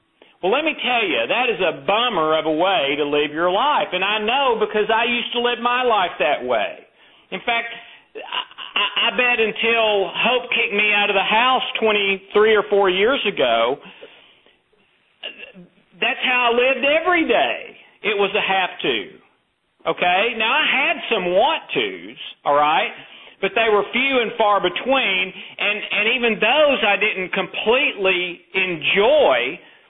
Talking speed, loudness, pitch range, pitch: 165 wpm, -18 LUFS, 195-245 Hz, 215 Hz